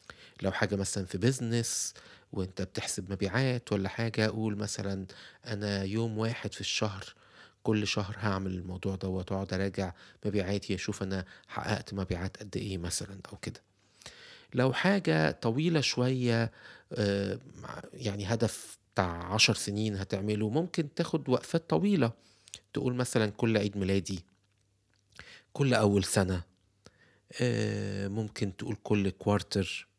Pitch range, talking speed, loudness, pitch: 95-115 Hz, 120 wpm, -32 LUFS, 105 Hz